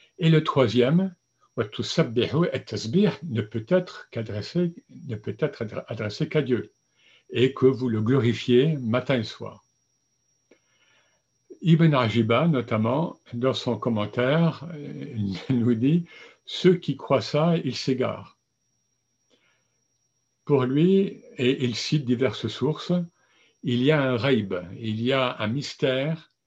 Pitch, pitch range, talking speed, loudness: 130 Hz, 120-160 Hz, 120 wpm, -24 LUFS